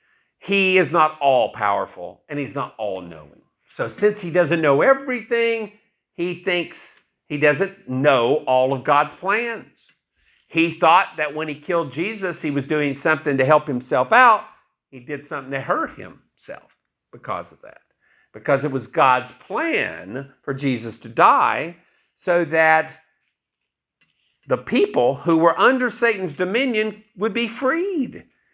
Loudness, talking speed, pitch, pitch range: -20 LUFS, 145 wpm, 165 Hz, 145-210 Hz